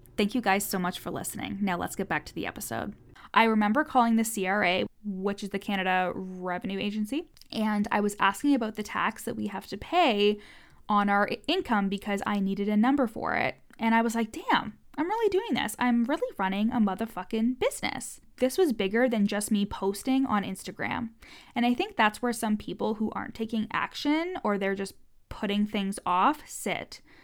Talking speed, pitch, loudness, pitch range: 195 wpm, 215 Hz, -28 LUFS, 200-245 Hz